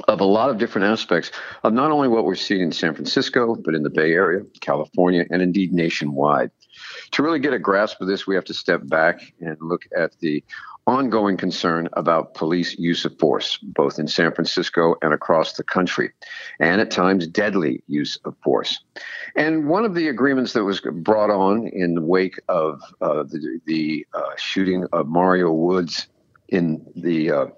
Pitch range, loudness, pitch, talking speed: 85-100 Hz, -20 LUFS, 90 Hz, 185 wpm